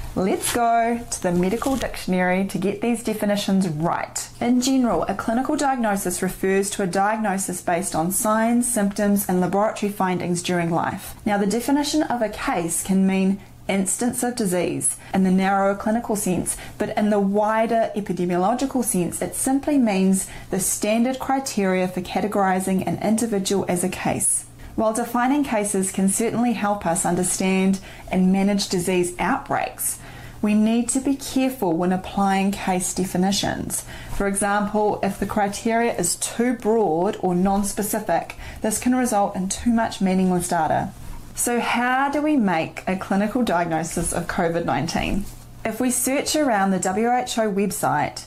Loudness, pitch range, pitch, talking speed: -22 LUFS, 185-230 Hz, 200 Hz, 150 wpm